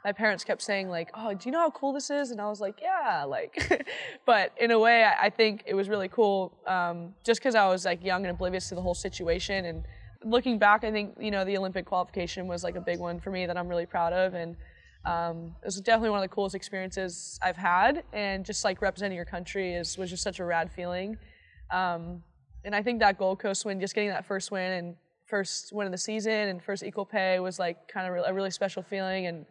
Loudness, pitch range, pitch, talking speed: -29 LUFS, 180-210 Hz, 190 Hz, 245 wpm